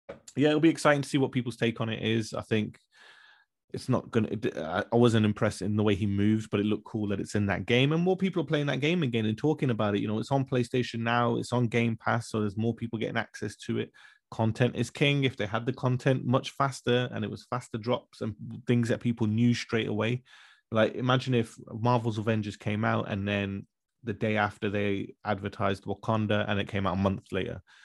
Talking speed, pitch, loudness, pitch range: 235 wpm, 115 Hz, -29 LUFS, 105-125 Hz